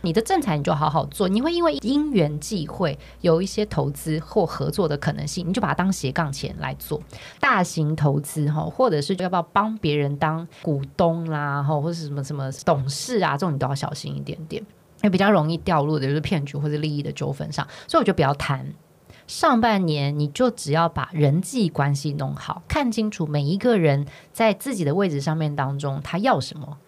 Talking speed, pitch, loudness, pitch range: 310 characters per minute, 160 Hz, -23 LUFS, 145-195 Hz